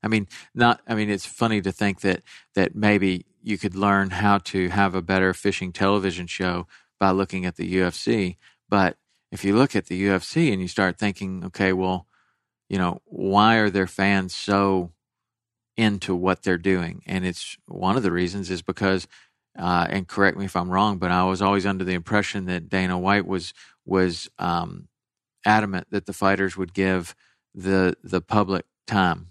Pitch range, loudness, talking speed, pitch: 90-100 Hz, -23 LUFS, 185 wpm, 95 Hz